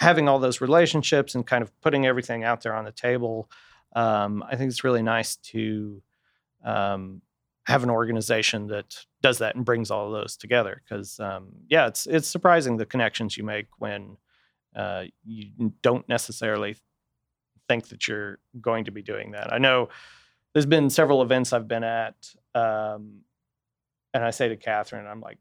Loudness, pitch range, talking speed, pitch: -25 LUFS, 105-130 Hz, 175 wpm, 115 Hz